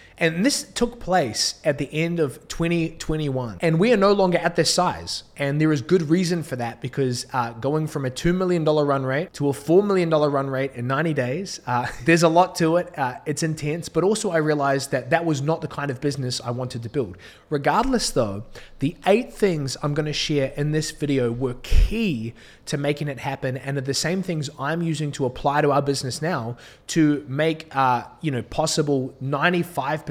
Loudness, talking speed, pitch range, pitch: -23 LUFS, 210 wpm, 135-165 Hz, 150 Hz